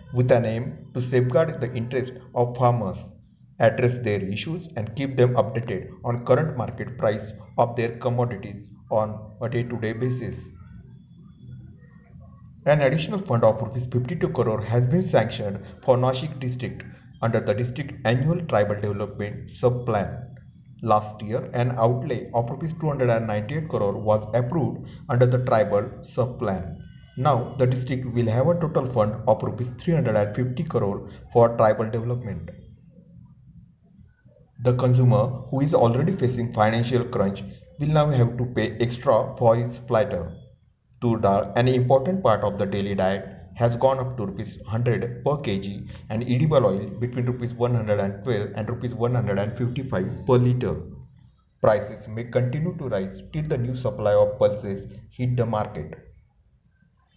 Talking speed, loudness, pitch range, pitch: 140 wpm, -24 LUFS, 110-130 Hz, 120 Hz